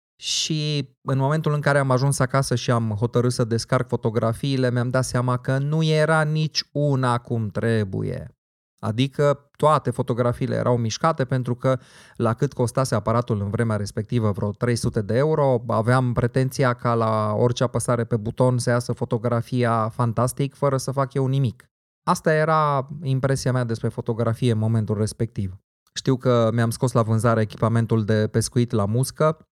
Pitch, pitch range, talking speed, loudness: 125 Hz, 115-135 Hz, 160 wpm, -22 LUFS